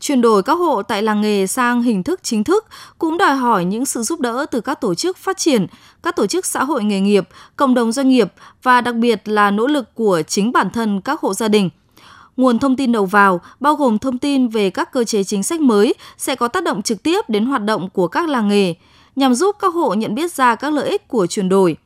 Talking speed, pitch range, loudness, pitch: 255 wpm, 210-285 Hz, -17 LUFS, 245 Hz